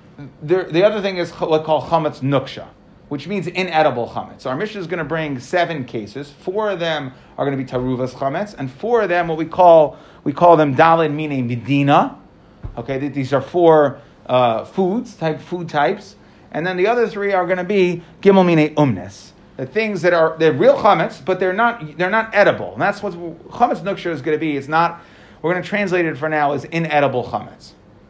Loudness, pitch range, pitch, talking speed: -18 LUFS, 140-185 Hz, 160 Hz, 215 wpm